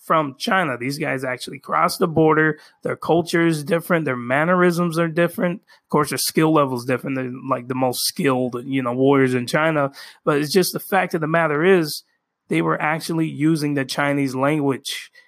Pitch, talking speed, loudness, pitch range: 155 Hz, 190 wpm, -20 LUFS, 135-170 Hz